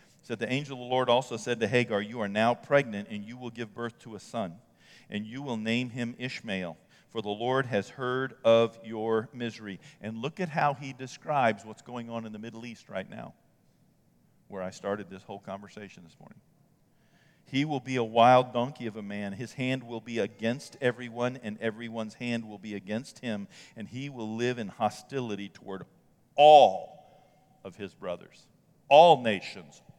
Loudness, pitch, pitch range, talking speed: -28 LUFS, 120 Hz, 110-130 Hz, 190 wpm